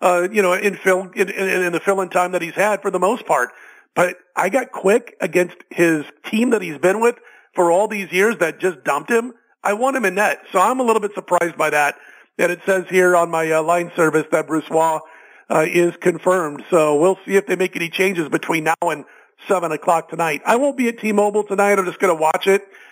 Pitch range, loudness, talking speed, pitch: 170-200 Hz, -18 LUFS, 240 wpm, 185 Hz